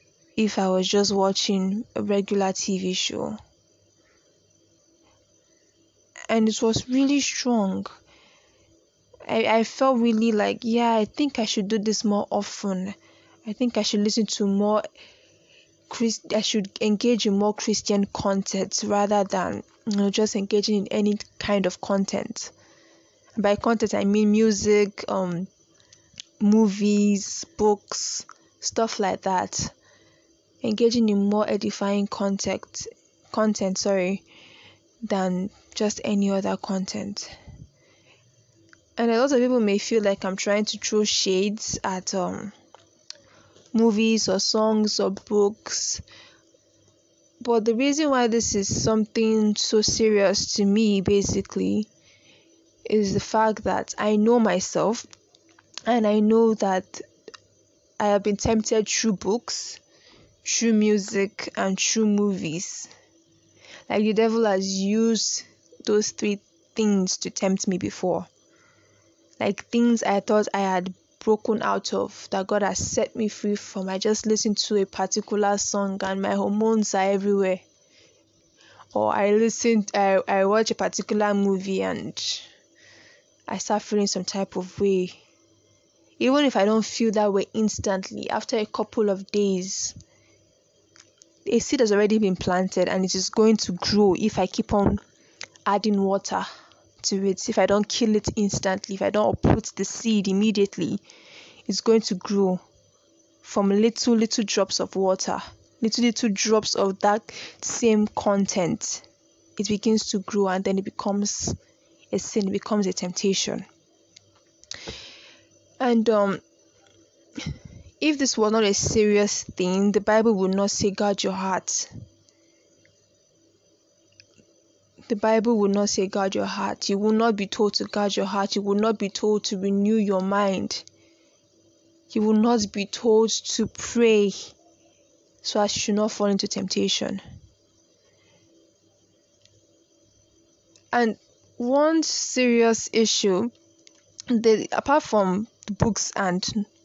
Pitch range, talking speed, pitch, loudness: 195-220 Hz, 135 wpm, 210 Hz, -23 LUFS